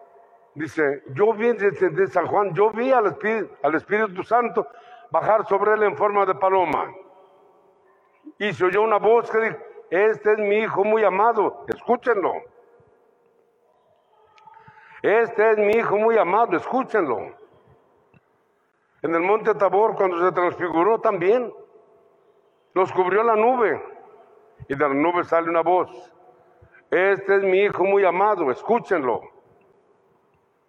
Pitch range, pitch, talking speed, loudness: 190-235 Hz, 210 Hz, 130 wpm, -21 LUFS